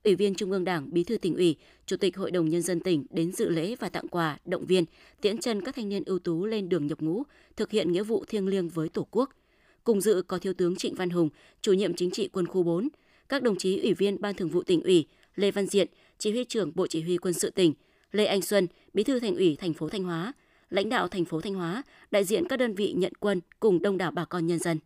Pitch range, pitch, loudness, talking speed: 175-215 Hz, 190 Hz, -28 LUFS, 270 wpm